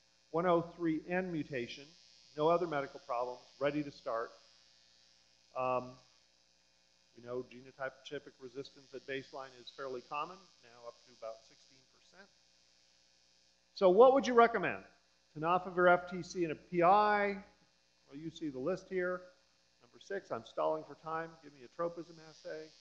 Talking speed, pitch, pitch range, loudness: 135 wpm, 140 Hz, 110-170 Hz, -34 LUFS